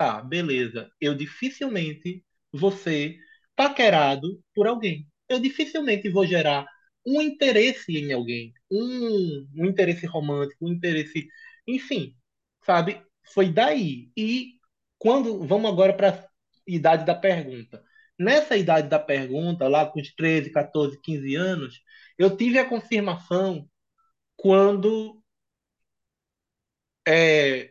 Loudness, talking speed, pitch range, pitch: -23 LUFS, 115 wpm, 150-220 Hz, 180 Hz